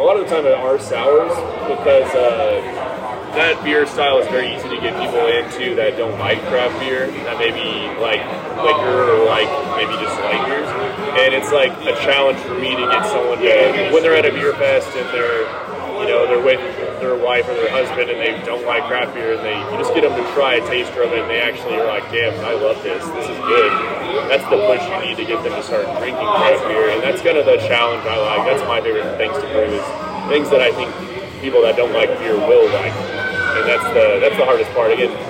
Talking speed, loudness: 240 wpm, -16 LUFS